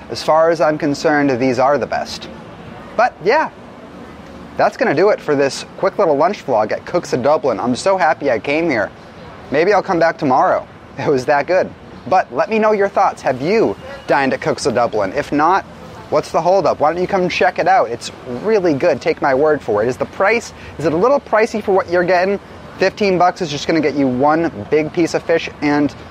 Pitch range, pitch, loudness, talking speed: 150-190 Hz, 165 Hz, -16 LUFS, 225 wpm